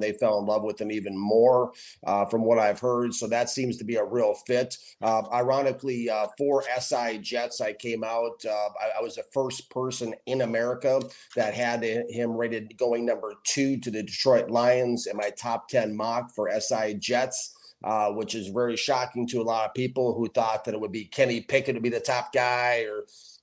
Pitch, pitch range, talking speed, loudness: 120 Hz, 110-125 Hz, 210 wpm, -27 LUFS